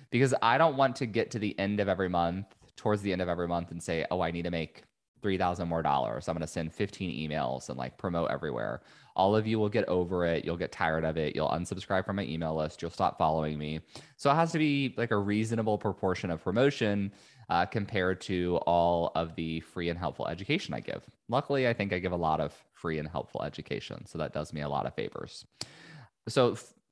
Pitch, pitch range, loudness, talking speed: 90 Hz, 80-105 Hz, -31 LUFS, 235 wpm